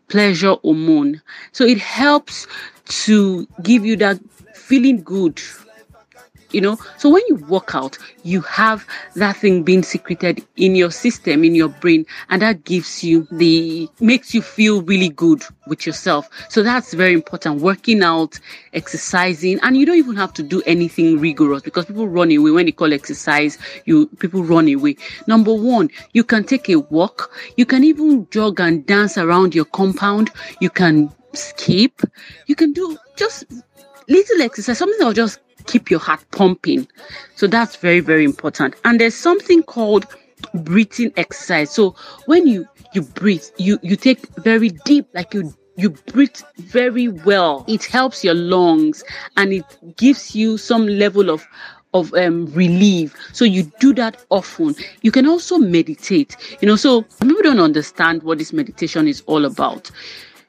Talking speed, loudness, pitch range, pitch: 165 wpm, -16 LUFS, 175-255 Hz, 205 Hz